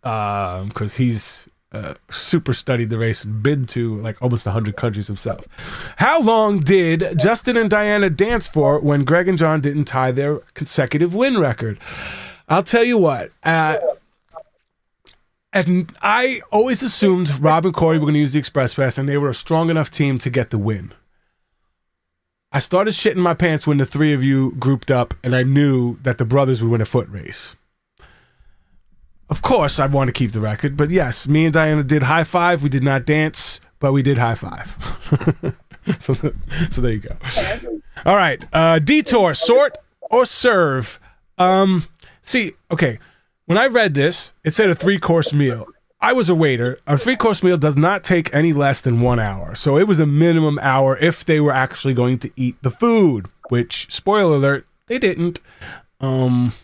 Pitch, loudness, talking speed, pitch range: 145 Hz, -17 LUFS, 185 wpm, 125-175 Hz